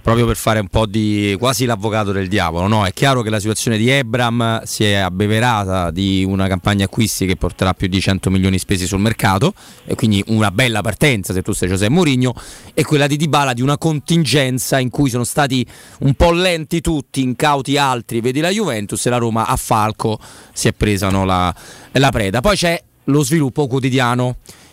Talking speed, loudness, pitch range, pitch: 200 wpm, -16 LUFS, 100-135 Hz, 115 Hz